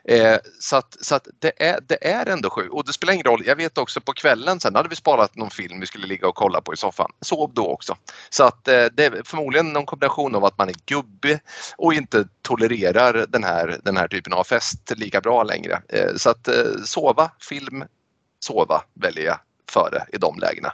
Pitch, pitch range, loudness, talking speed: 140 Hz, 100-160 Hz, -20 LUFS, 225 wpm